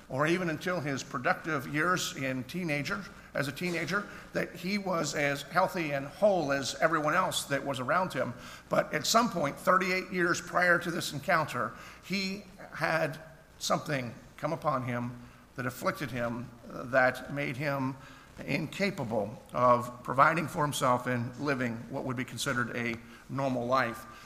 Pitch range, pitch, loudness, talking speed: 130-175 Hz, 145 Hz, -31 LUFS, 150 wpm